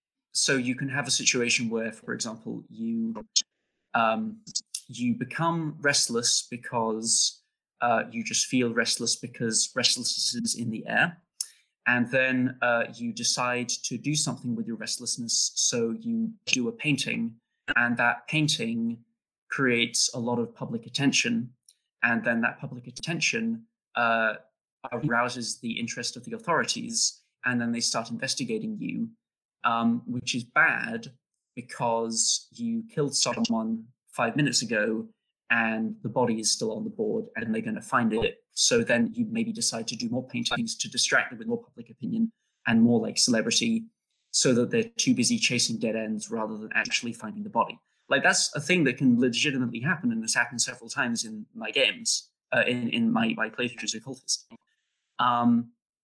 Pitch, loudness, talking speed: 135 Hz, -26 LUFS, 165 wpm